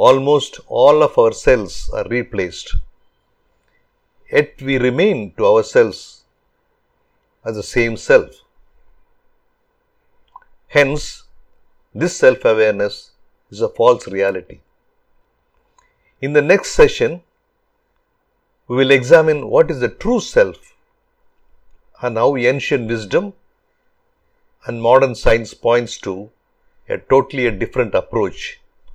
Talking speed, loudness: 100 wpm, -16 LUFS